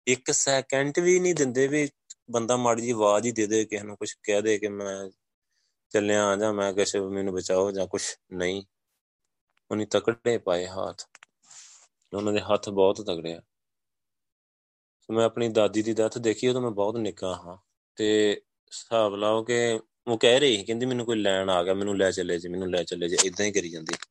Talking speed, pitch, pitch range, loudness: 190 wpm, 105 Hz, 95-115 Hz, -26 LUFS